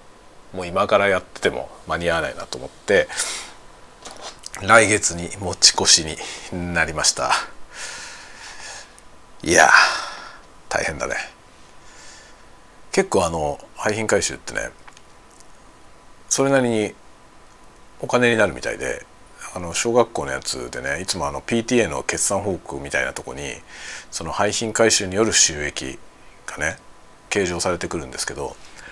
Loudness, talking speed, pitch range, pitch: -20 LUFS, 250 characters per minute, 85-115 Hz, 105 Hz